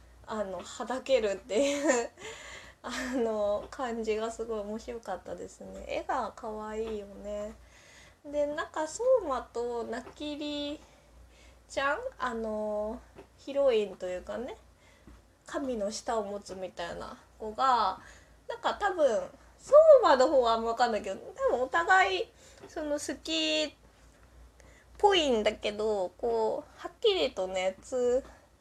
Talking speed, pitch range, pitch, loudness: 240 characters per minute, 215-305 Hz, 245 Hz, -30 LUFS